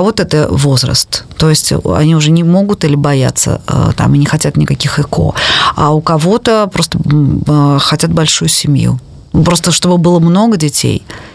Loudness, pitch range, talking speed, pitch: -10 LUFS, 145-175 Hz, 155 wpm, 155 Hz